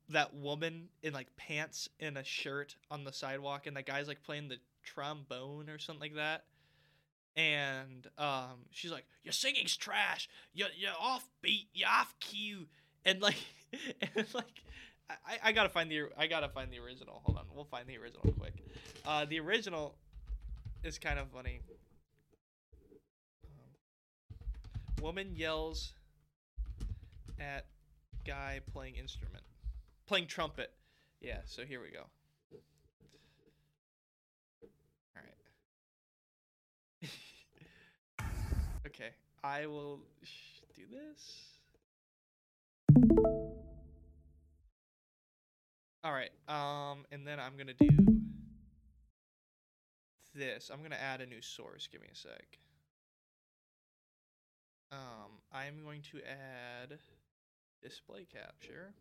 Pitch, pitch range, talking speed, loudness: 140 Hz, 95-155 Hz, 115 wpm, -36 LUFS